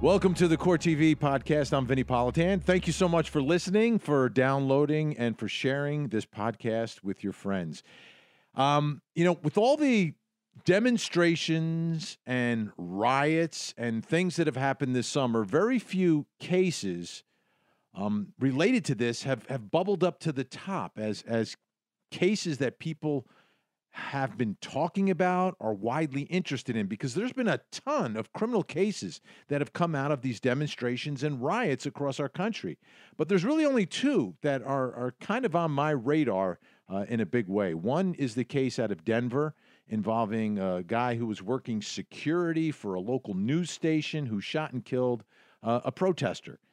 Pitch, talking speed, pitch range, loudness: 145 Hz, 170 wpm, 120-170 Hz, -29 LUFS